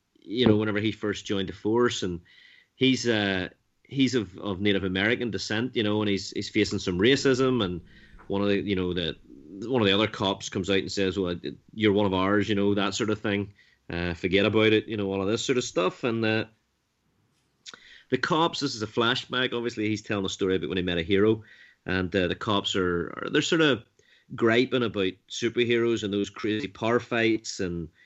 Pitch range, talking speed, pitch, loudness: 95-115 Hz, 215 wpm, 105 Hz, -26 LUFS